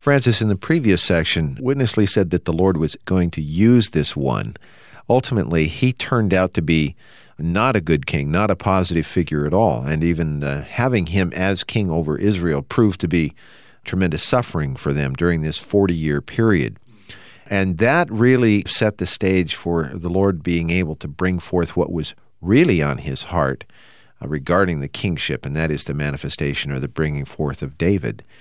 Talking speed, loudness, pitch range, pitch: 185 wpm, -19 LUFS, 80-105 Hz, 90 Hz